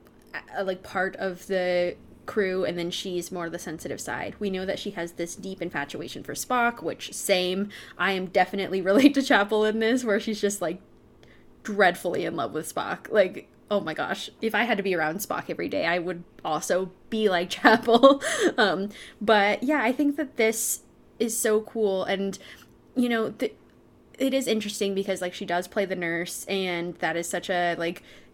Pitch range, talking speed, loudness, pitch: 180-220 Hz, 190 wpm, -26 LUFS, 195 Hz